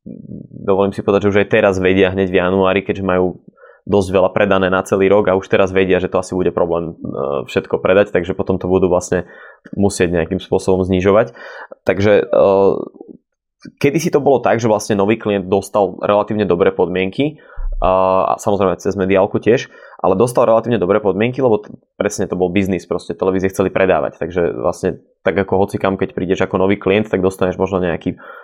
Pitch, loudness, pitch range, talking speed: 95 Hz, -16 LUFS, 95-100 Hz, 180 wpm